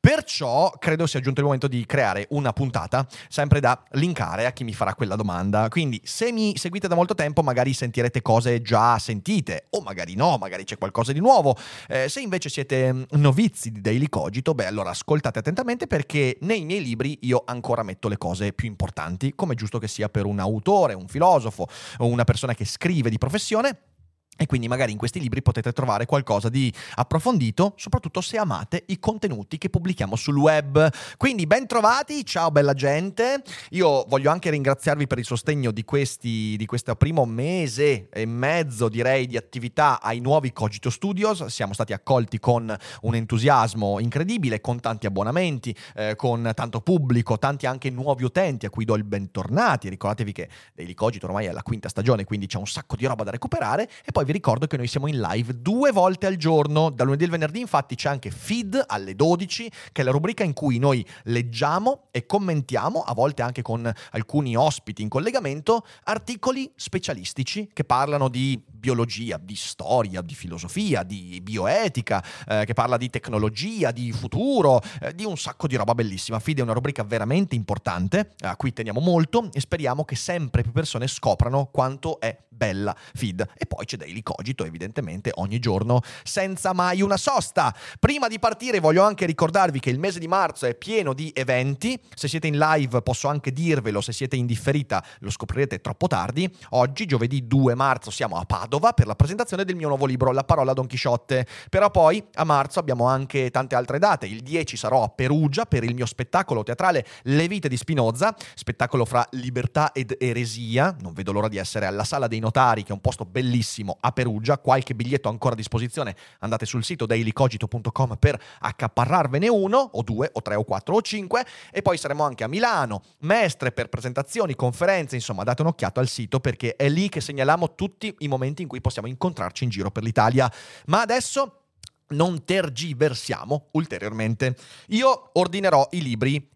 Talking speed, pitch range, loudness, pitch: 185 wpm, 115-155 Hz, -24 LUFS, 130 Hz